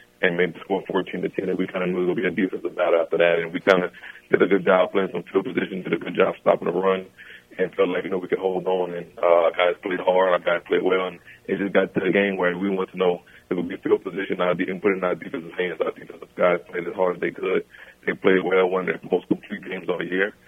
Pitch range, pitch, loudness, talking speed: 90-95 Hz, 90 Hz, -23 LUFS, 305 wpm